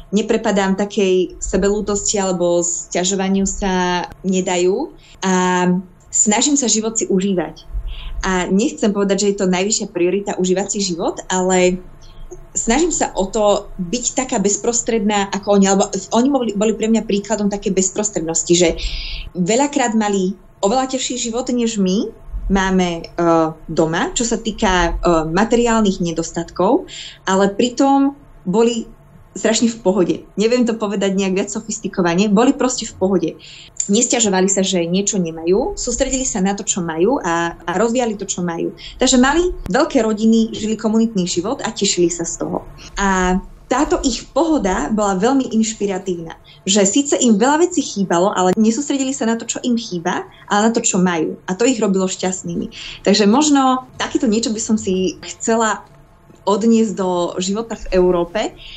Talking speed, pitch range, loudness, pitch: 150 wpm, 180-230 Hz, -17 LUFS, 200 Hz